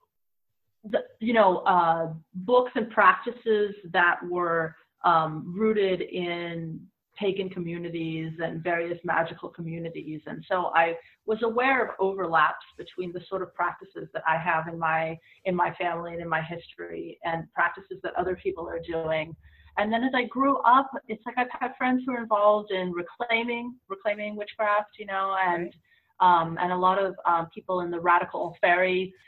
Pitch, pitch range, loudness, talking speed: 185 Hz, 170-215 Hz, -26 LUFS, 165 wpm